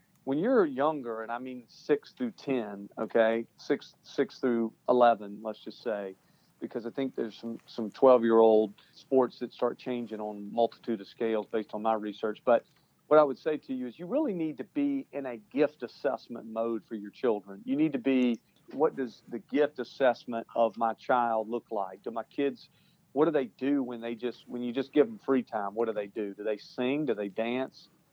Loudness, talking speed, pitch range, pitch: -30 LUFS, 215 wpm, 110-135 Hz, 120 Hz